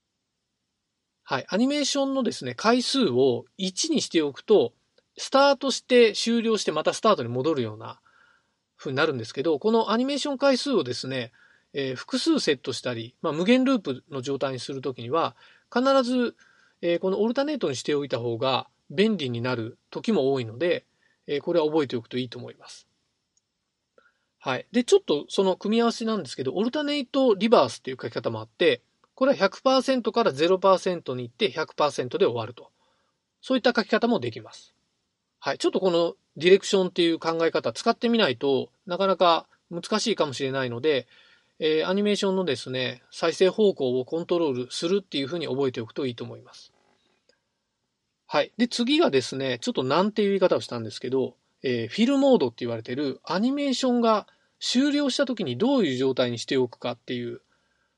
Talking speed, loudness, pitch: 385 characters per minute, -25 LUFS, 190 Hz